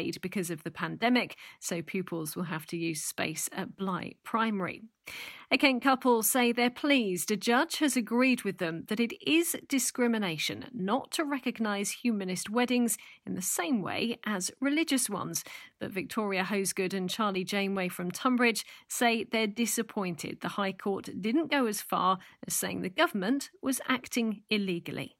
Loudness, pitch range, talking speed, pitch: -30 LUFS, 185-250 Hz, 160 wpm, 220 Hz